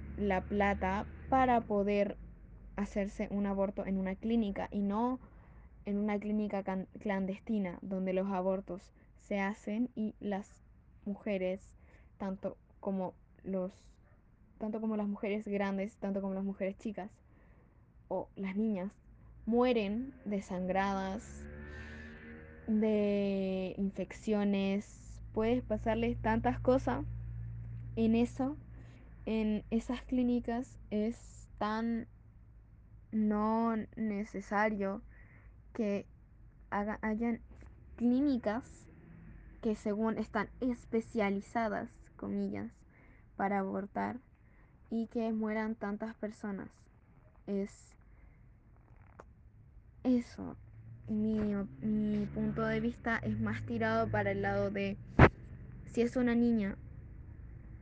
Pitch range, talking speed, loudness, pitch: 185-220 Hz, 95 wpm, -35 LUFS, 200 Hz